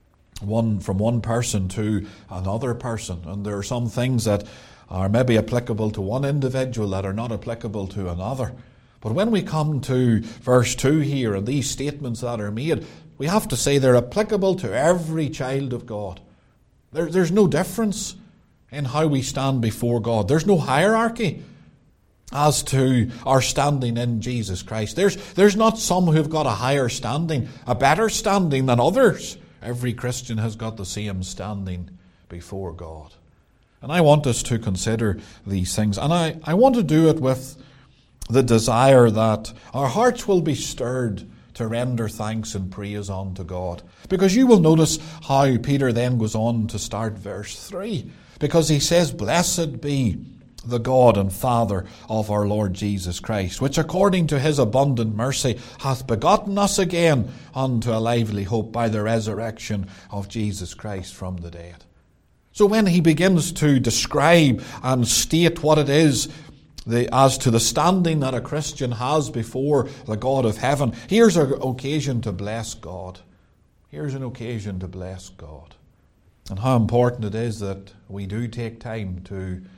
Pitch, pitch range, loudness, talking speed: 120 Hz, 105-145 Hz, -21 LUFS, 165 wpm